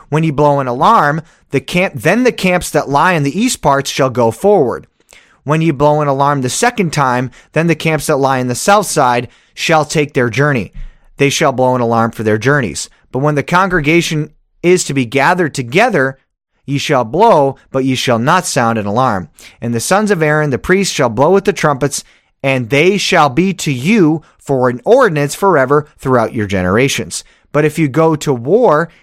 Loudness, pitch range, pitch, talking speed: -13 LUFS, 130-165 Hz, 145 Hz, 205 wpm